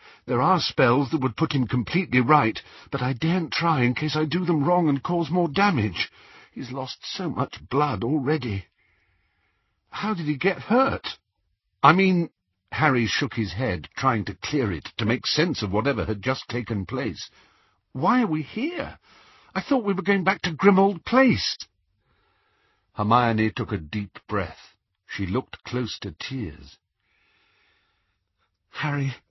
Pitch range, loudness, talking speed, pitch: 110-175 Hz, -24 LUFS, 160 wpm, 140 Hz